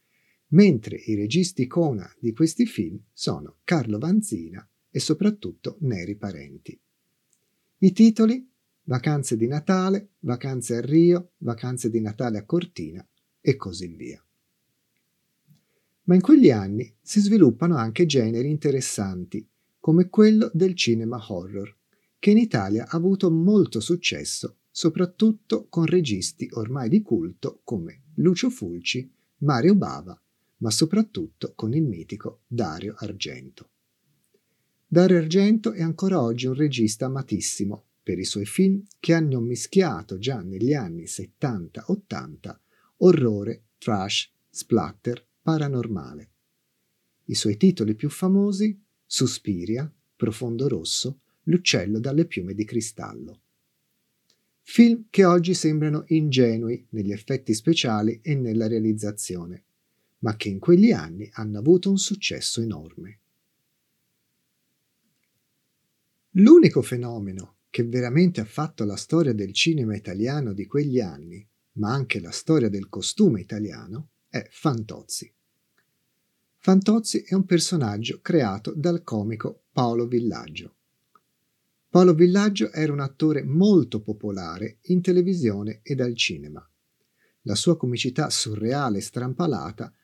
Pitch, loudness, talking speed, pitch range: 130 Hz, -23 LUFS, 115 wpm, 110-175 Hz